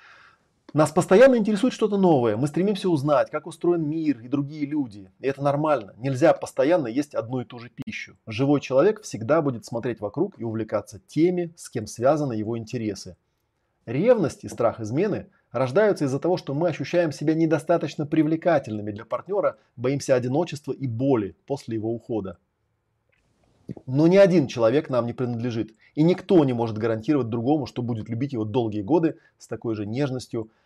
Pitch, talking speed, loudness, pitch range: 140 Hz, 165 wpm, -24 LUFS, 115-160 Hz